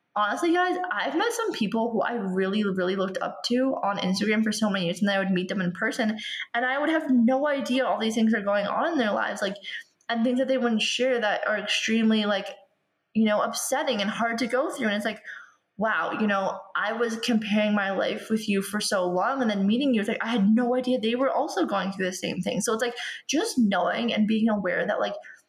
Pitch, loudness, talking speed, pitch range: 220 Hz, -25 LUFS, 245 wpm, 200-245 Hz